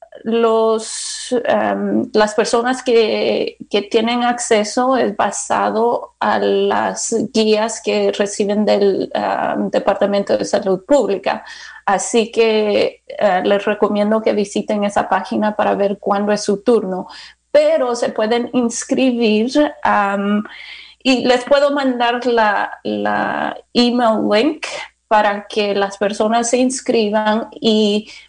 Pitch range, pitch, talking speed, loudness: 205-240 Hz, 220 Hz, 120 wpm, -16 LUFS